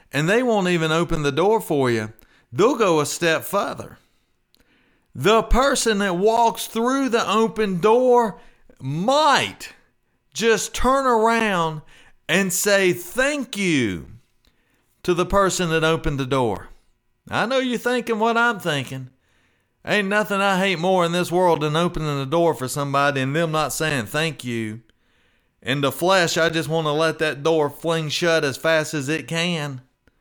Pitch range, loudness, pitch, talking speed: 145-210 Hz, -20 LUFS, 165 Hz, 160 wpm